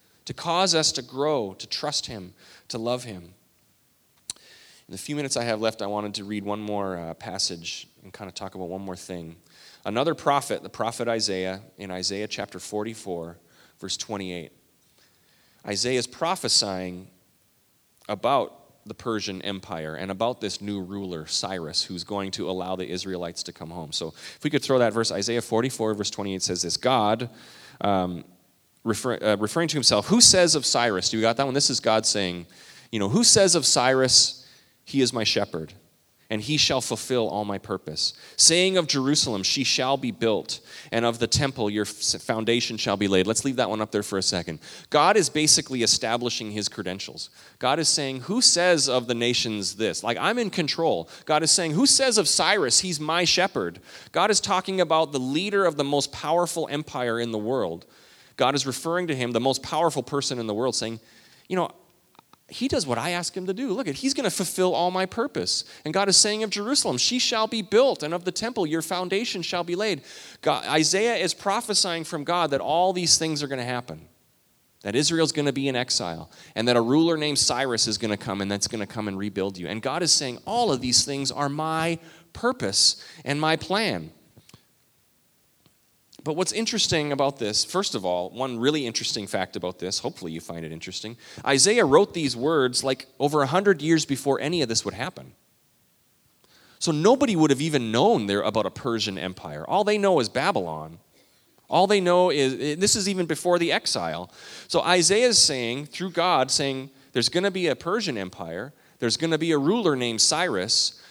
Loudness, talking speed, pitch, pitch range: -23 LUFS, 200 wpm, 125 Hz, 105-160 Hz